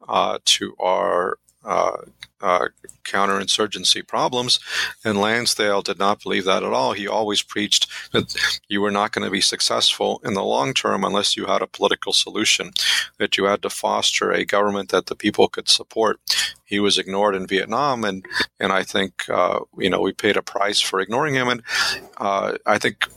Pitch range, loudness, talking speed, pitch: 100-105 Hz, -20 LUFS, 185 wpm, 100 Hz